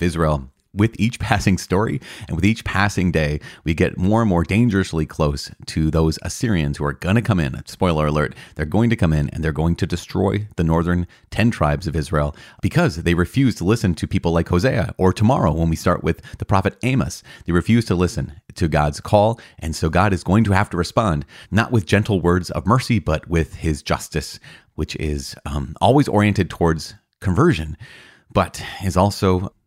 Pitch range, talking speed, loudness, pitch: 80-105 Hz, 200 wpm, -20 LUFS, 90 Hz